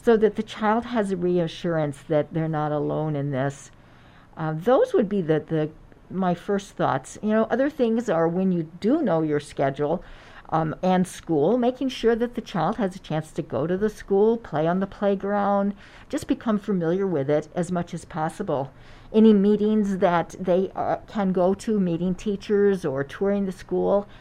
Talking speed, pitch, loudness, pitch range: 190 wpm, 185 Hz, -24 LUFS, 155-210 Hz